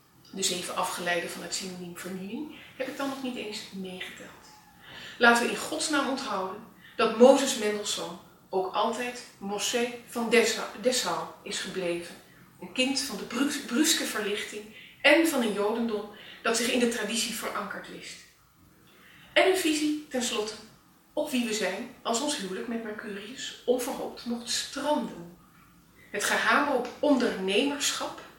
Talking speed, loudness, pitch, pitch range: 140 wpm, -28 LUFS, 225 Hz, 195-255 Hz